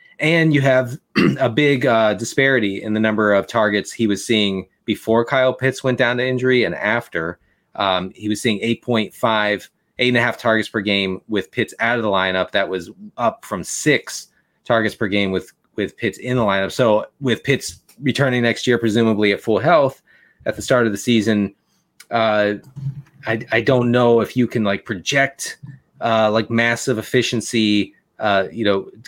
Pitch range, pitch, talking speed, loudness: 105-125 Hz, 115 Hz, 190 wpm, -18 LUFS